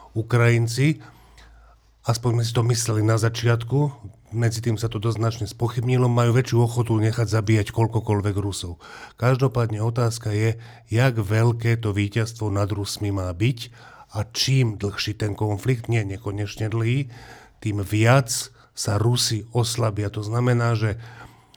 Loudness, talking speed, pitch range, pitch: -23 LUFS, 130 wpm, 105-120 Hz, 115 Hz